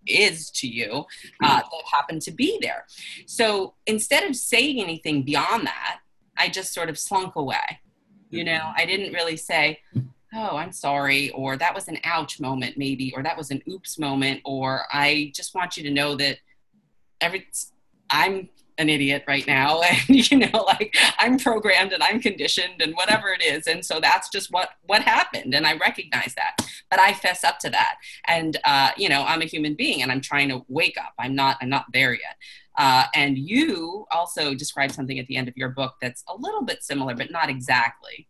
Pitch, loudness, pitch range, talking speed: 160 Hz, -22 LUFS, 140-205 Hz, 200 wpm